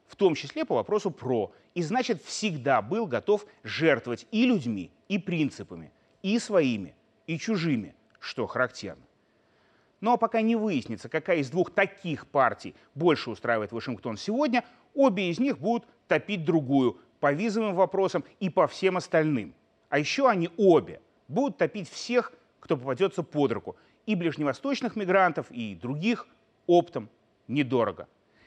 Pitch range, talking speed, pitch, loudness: 140-225 Hz, 140 wpm, 180 Hz, -27 LUFS